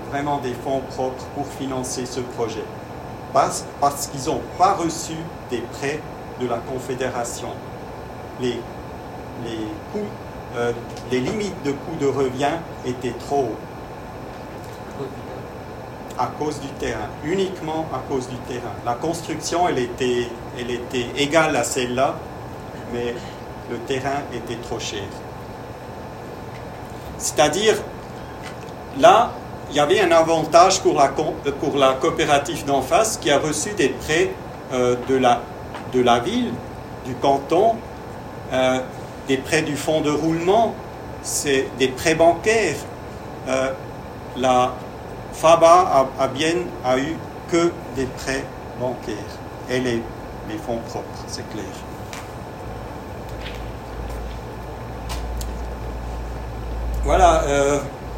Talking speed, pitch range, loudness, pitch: 120 wpm, 120-145 Hz, -21 LUFS, 130 Hz